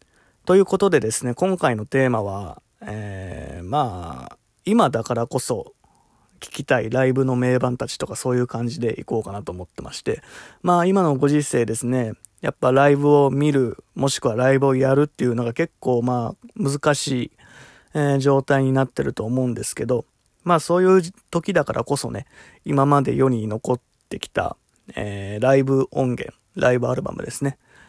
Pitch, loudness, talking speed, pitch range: 130 Hz, -21 LUFS, 340 characters per minute, 115-145 Hz